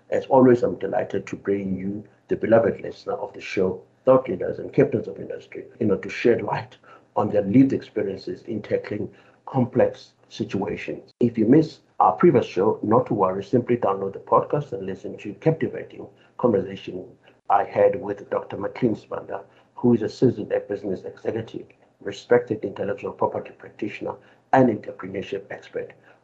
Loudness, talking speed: -23 LUFS, 160 wpm